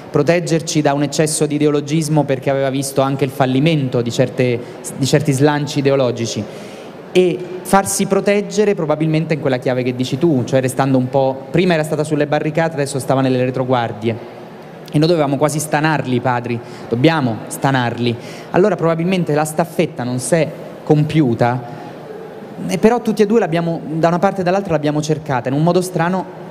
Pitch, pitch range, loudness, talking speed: 150 Hz, 130-170 Hz, -16 LUFS, 165 wpm